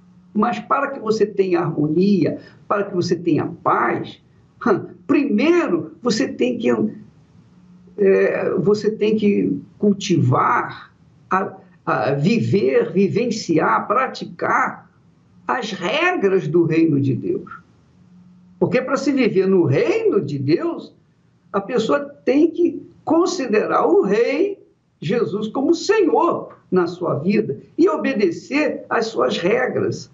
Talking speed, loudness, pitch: 115 wpm, -19 LUFS, 205 Hz